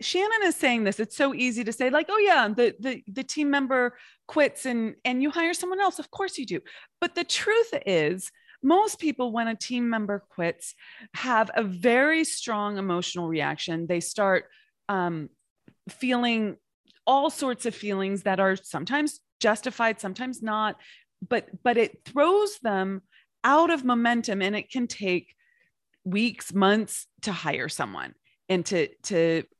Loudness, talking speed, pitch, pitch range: -26 LUFS, 160 wpm, 240 Hz, 200-290 Hz